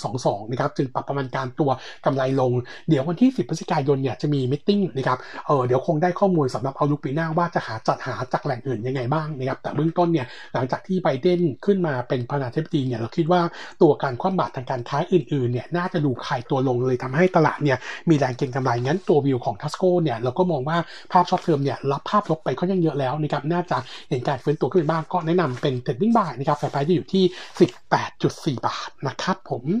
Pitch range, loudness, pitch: 130-175 Hz, -23 LUFS, 150 Hz